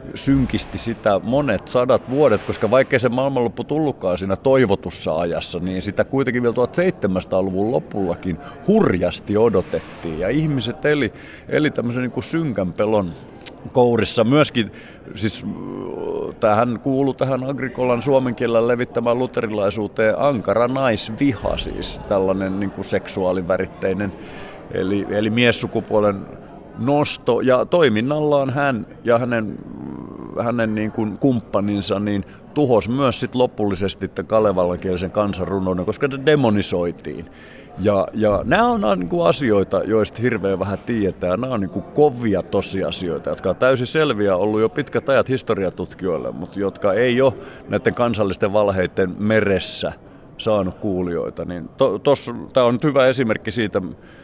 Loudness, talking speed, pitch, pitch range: -20 LUFS, 125 wpm, 110 Hz, 100-130 Hz